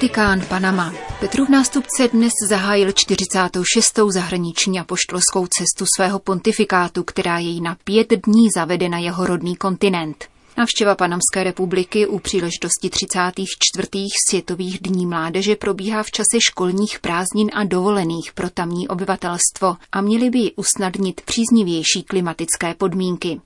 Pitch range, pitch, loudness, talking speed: 180-210 Hz, 190 Hz, -18 LUFS, 125 wpm